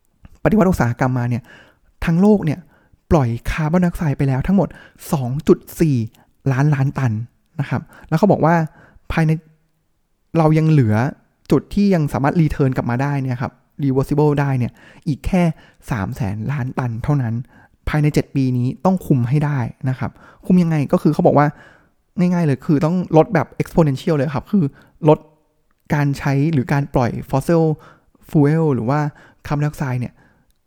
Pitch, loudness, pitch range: 150 Hz, -18 LUFS, 130-160 Hz